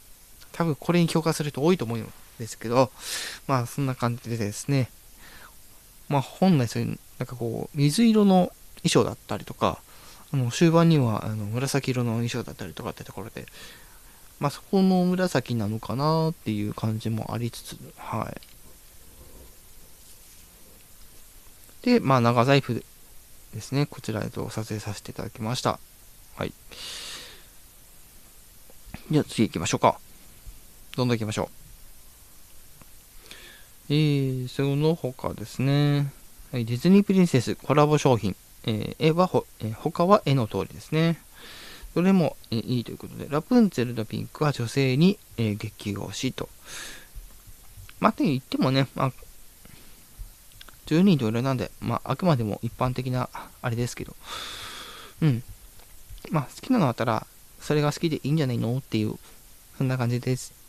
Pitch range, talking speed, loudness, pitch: 110-150 Hz, 290 characters per minute, -25 LUFS, 125 Hz